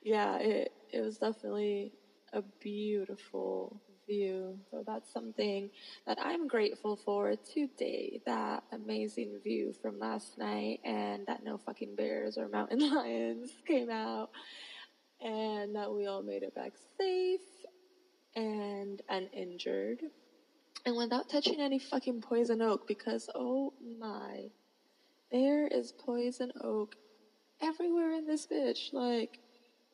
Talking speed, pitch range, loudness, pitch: 120 wpm, 190-280 Hz, -37 LUFS, 225 Hz